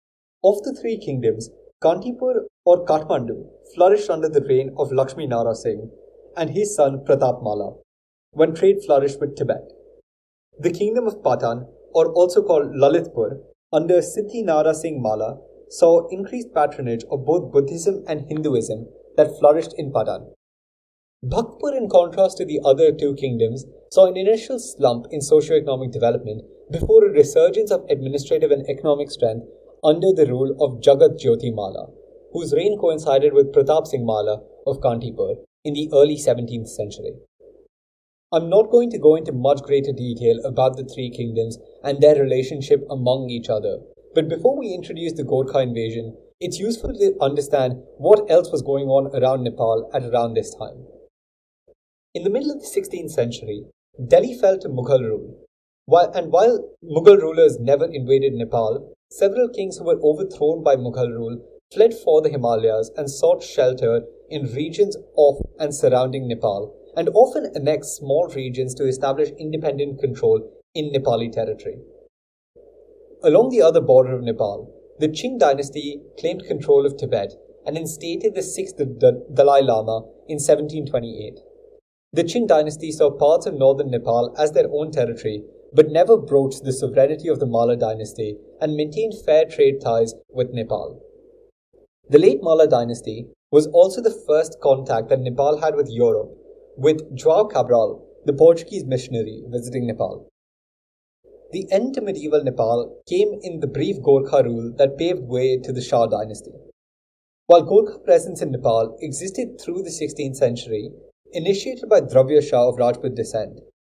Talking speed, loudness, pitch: 155 wpm, -19 LUFS, 165 Hz